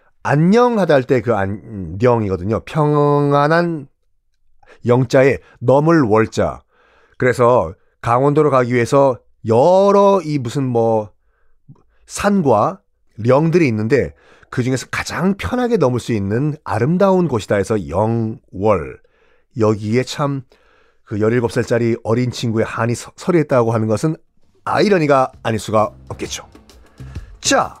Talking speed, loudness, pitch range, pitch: 240 characters per minute, -16 LUFS, 110-150 Hz, 125 Hz